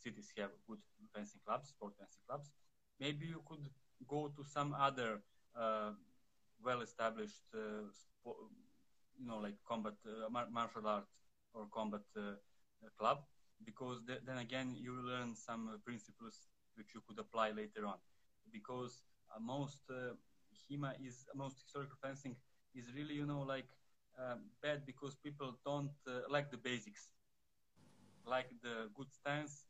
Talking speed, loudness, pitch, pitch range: 150 wpm, -46 LUFS, 125 Hz, 110-140 Hz